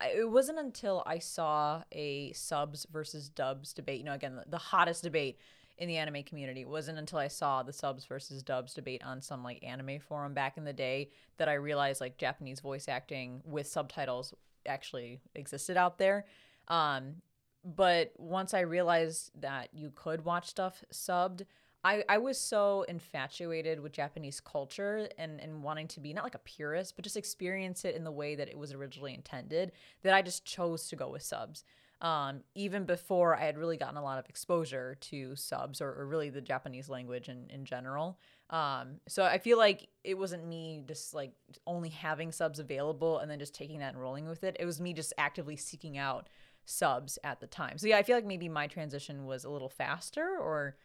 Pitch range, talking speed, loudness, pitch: 140-175 Hz, 200 wpm, -36 LUFS, 155 Hz